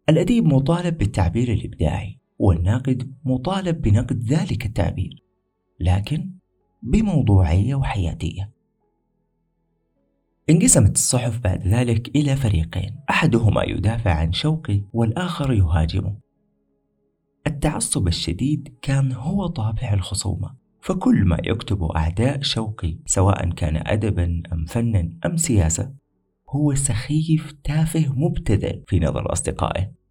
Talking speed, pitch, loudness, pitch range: 100 wpm, 110 Hz, -21 LUFS, 90-140 Hz